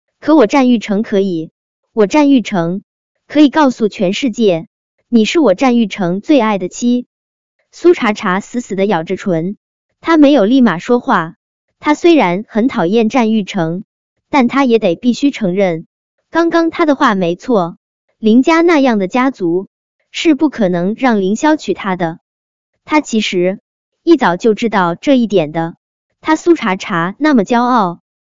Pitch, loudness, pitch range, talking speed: 225 Hz, -13 LUFS, 190-280 Hz, 225 characters per minute